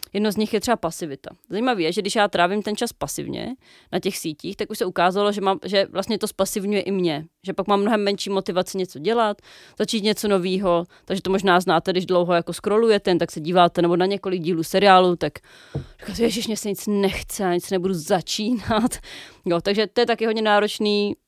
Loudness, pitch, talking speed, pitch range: -22 LUFS, 195 Hz, 215 wpm, 180-210 Hz